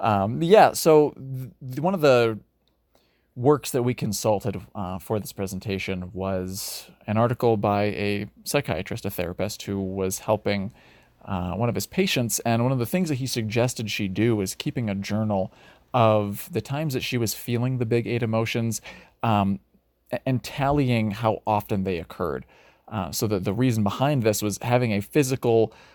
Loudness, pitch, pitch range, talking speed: -24 LUFS, 110 Hz, 100-125 Hz, 170 wpm